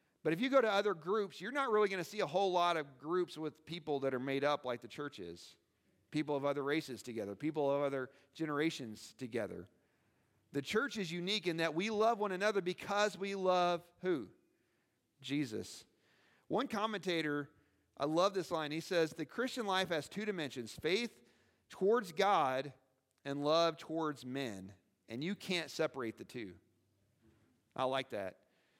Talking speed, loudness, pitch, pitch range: 175 wpm, -37 LUFS, 155 Hz, 130-185 Hz